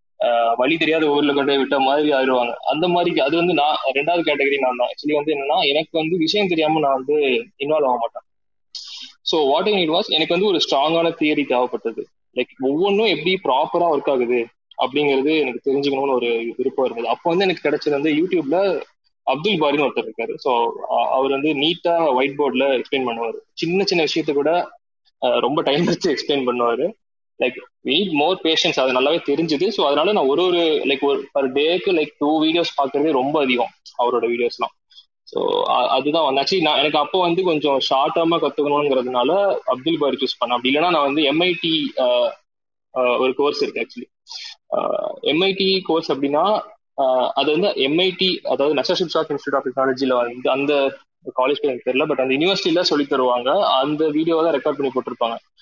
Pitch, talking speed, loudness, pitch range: 155 Hz, 160 wpm, -19 LUFS, 135-180 Hz